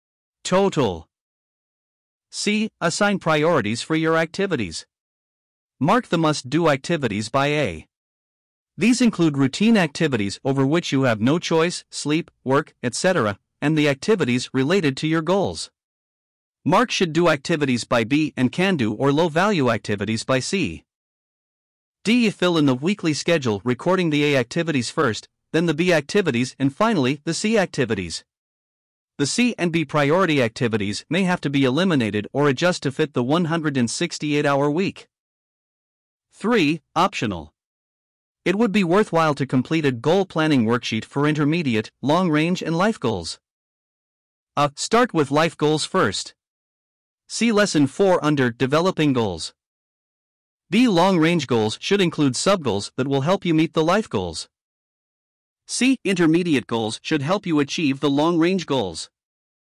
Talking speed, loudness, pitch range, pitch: 140 wpm, -21 LUFS, 125-170 Hz, 150 Hz